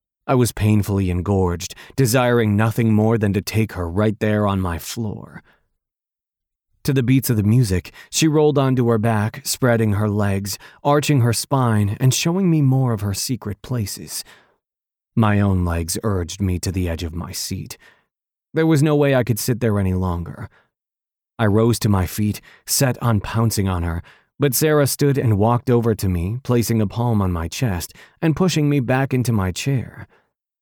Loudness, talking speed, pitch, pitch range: -19 LUFS, 180 wpm, 110 Hz, 100-130 Hz